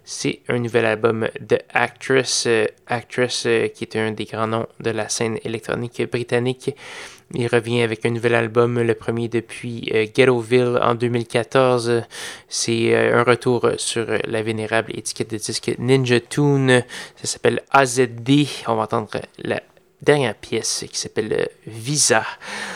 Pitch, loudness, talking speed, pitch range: 120 Hz, -20 LUFS, 155 wpm, 115-125 Hz